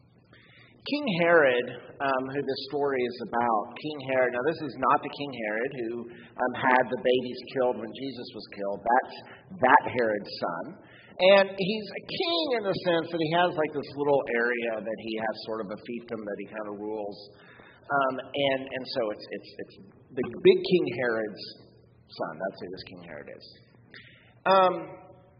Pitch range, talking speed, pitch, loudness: 115-165 Hz, 180 wpm, 130 Hz, -27 LUFS